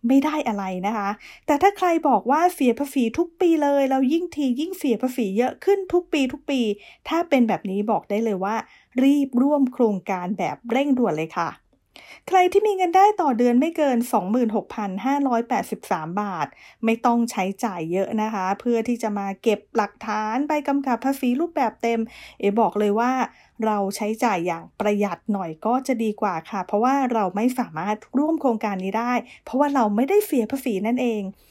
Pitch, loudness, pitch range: 240 Hz, -22 LUFS, 210-275 Hz